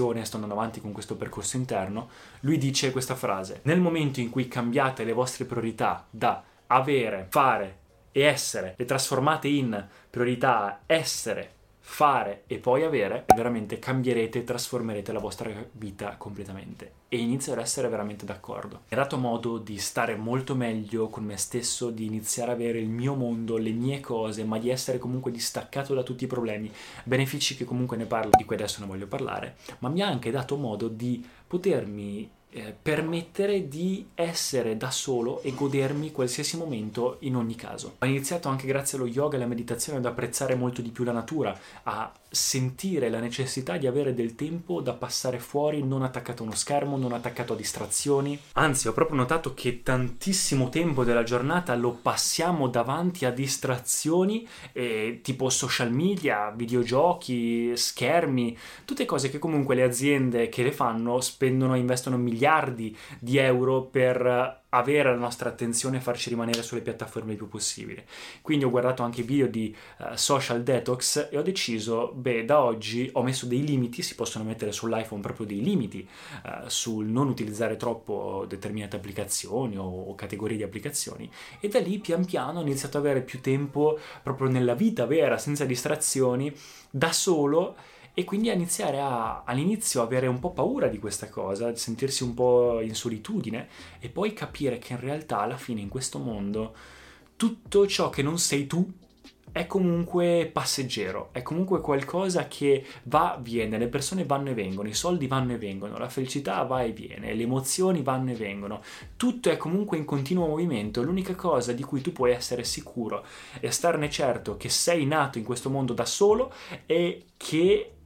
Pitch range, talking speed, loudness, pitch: 115-145 Hz, 175 wpm, -27 LUFS, 125 Hz